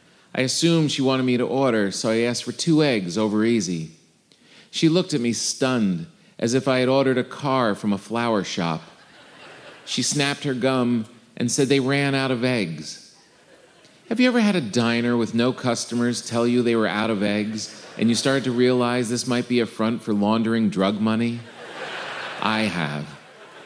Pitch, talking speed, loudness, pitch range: 120 Hz, 190 wpm, -22 LUFS, 110-130 Hz